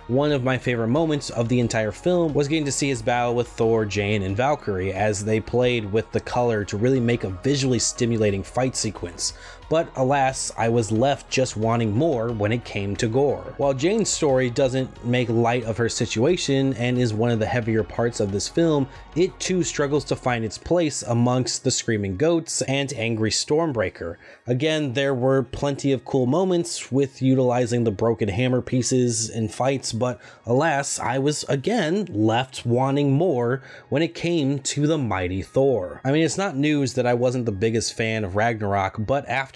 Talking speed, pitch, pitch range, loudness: 190 wpm, 125 Hz, 115-140 Hz, -23 LUFS